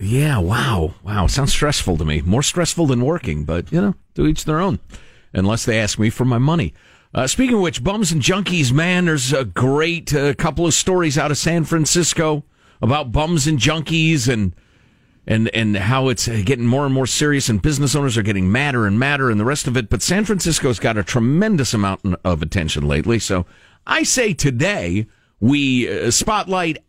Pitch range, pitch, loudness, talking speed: 110-160 Hz, 135 Hz, -18 LUFS, 195 wpm